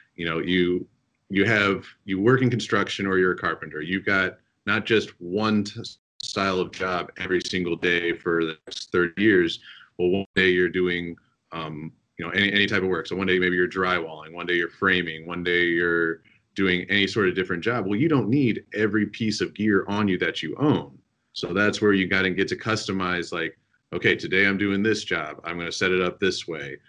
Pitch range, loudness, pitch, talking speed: 90-100 Hz, -23 LUFS, 95 Hz, 220 wpm